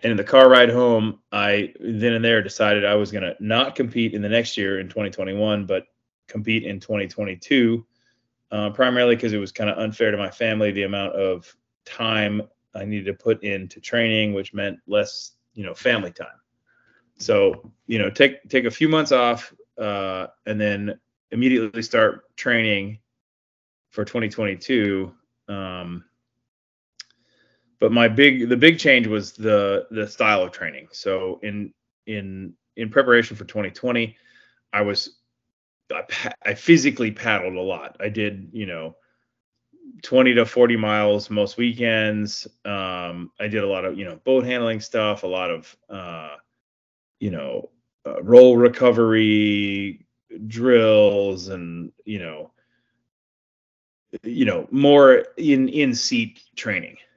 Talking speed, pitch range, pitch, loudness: 150 wpm, 100-120 Hz, 110 Hz, -20 LUFS